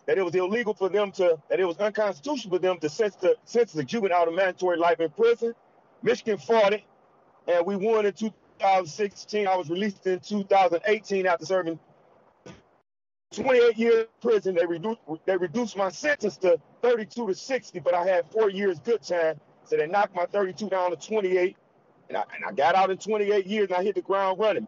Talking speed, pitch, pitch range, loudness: 200 wpm, 200 Hz, 180-220 Hz, -25 LUFS